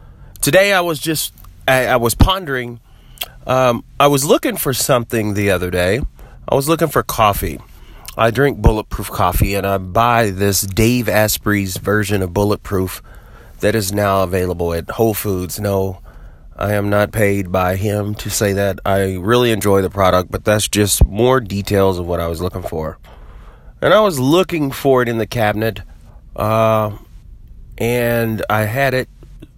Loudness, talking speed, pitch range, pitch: -16 LUFS, 165 wpm, 95-120 Hz, 105 Hz